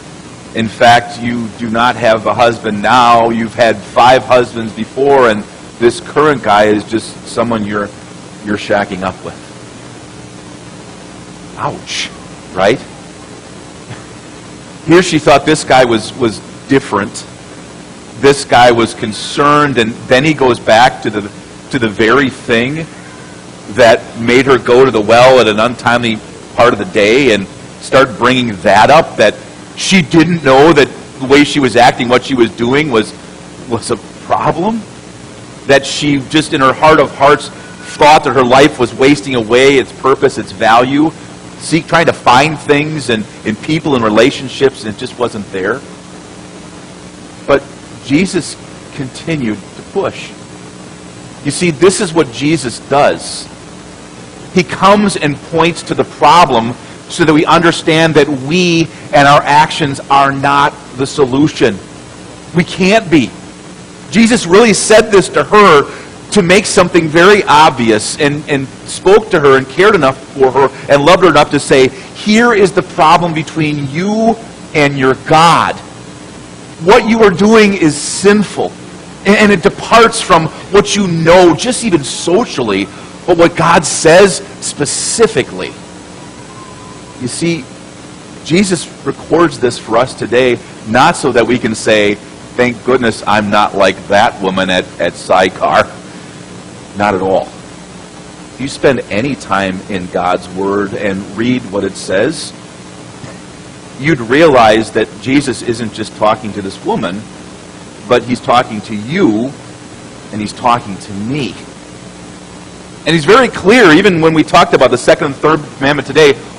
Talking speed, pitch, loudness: 150 wpm, 120 Hz, -10 LUFS